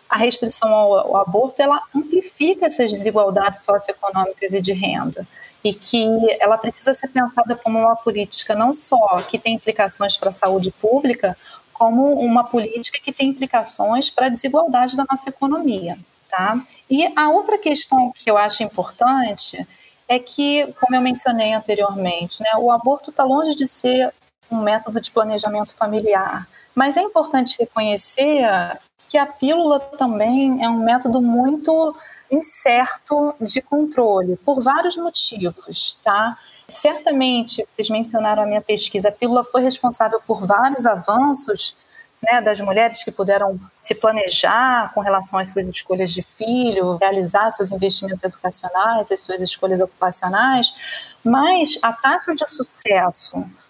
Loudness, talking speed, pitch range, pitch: -18 LUFS, 145 wpm, 205-270 Hz, 230 Hz